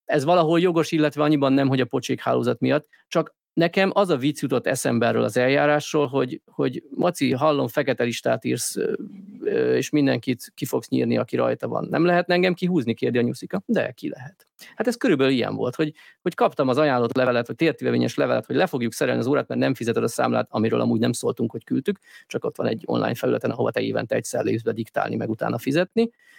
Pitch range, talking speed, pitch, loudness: 130-180 Hz, 215 wpm, 150 Hz, -23 LUFS